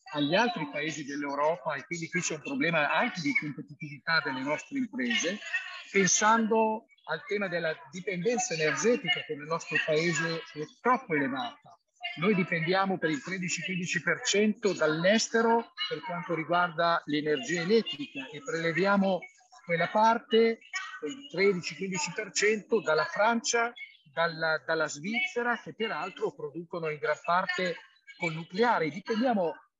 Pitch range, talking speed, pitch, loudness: 165-230 Hz, 120 wpm, 185 Hz, -29 LUFS